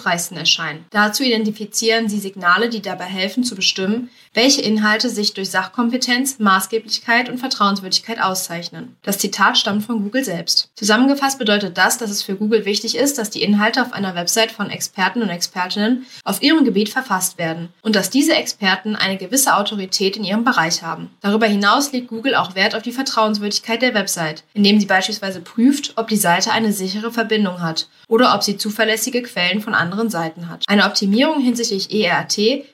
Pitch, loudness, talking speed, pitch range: 210 Hz, -17 LUFS, 175 wpm, 190-235 Hz